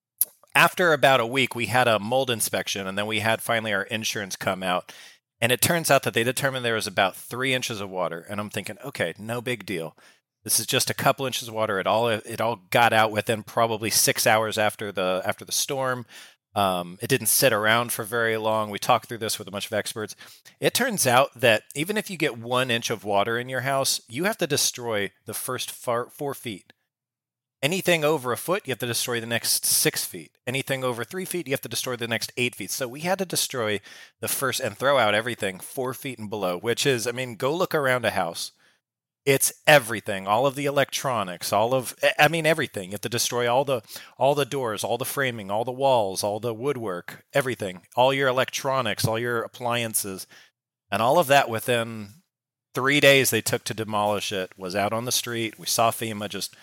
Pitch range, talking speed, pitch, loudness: 110-130 Hz, 220 wpm, 120 Hz, -24 LUFS